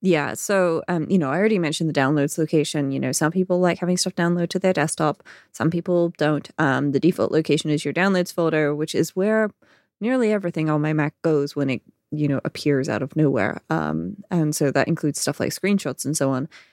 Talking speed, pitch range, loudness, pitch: 220 wpm, 145-180 Hz, -22 LUFS, 155 Hz